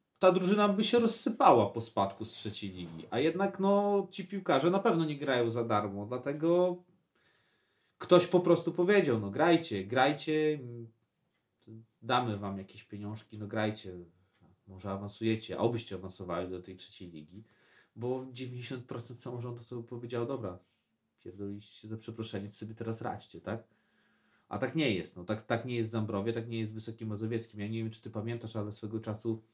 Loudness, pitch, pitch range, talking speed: -31 LUFS, 115 Hz, 105-135 Hz, 175 wpm